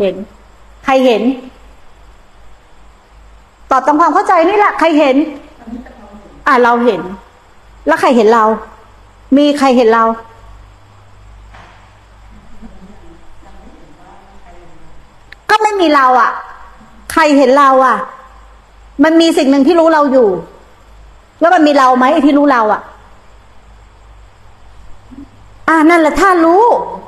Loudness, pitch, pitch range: -10 LUFS, 260 Hz, 190-305 Hz